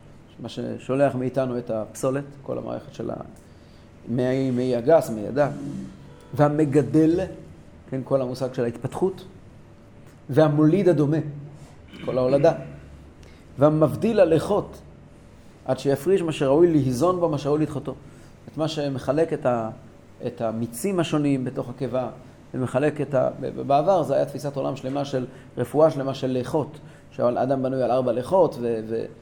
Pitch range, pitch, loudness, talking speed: 120-150 Hz, 135 Hz, -23 LUFS, 130 wpm